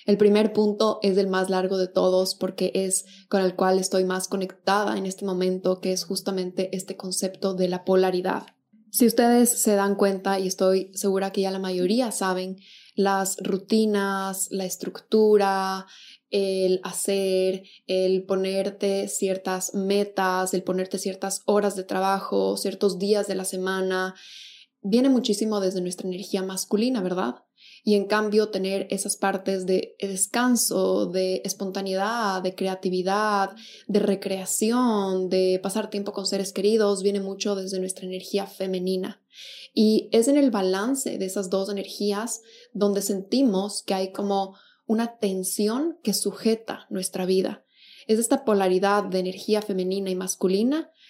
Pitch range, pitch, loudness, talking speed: 190-205 Hz, 195 Hz, -24 LUFS, 145 wpm